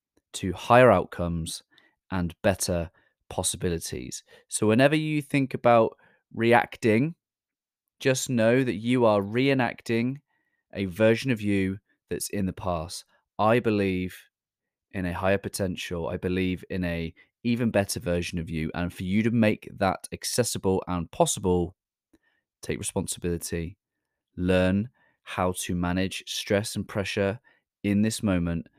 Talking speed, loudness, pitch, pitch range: 130 wpm, -26 LUFS, 100 Hz, 90-115 Hz